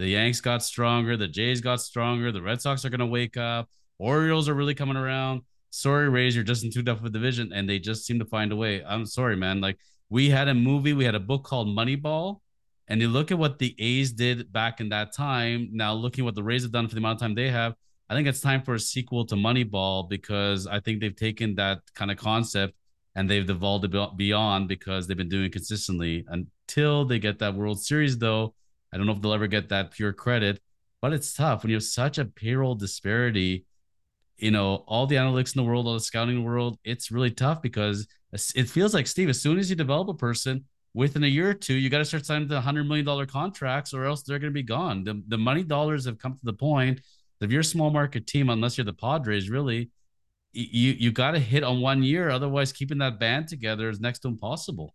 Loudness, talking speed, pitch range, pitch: -26 LUFS, 240 wpm, 105-135 Hz, 120 Hz